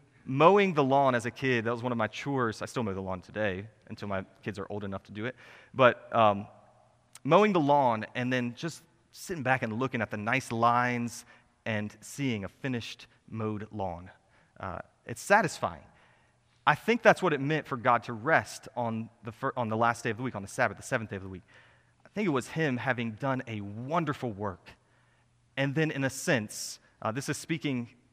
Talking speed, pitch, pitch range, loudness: 215 wpm, 120 Hz, 110-135 Hz, -29 LUFS